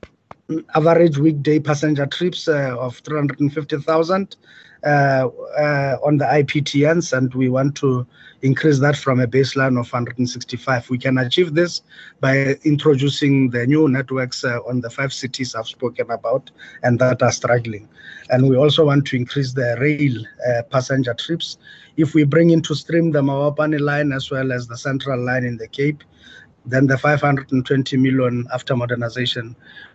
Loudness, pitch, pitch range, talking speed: -18 LUFS, 135 Hz, 125-150 Hz, 155 wpm